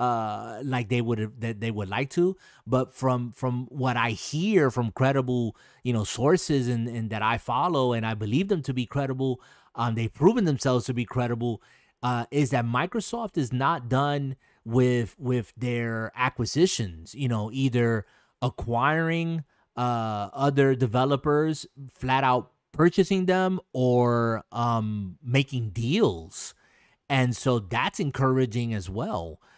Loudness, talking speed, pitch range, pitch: -26 LUFS, 145 wpm, 115-140 Hz, 125 Hz